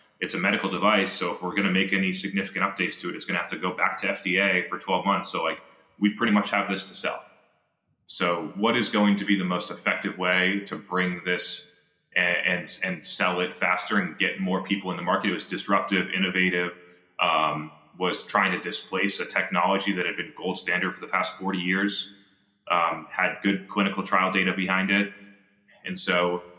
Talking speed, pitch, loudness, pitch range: 210 wpm, 95 Hz, -25 LUFS, 90-100 Hz